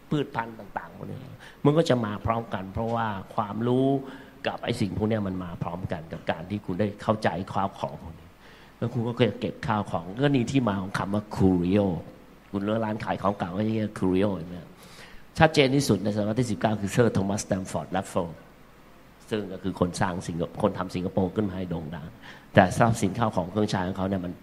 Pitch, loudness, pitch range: 105 Hz, -27 LUFS, 95-115 Hz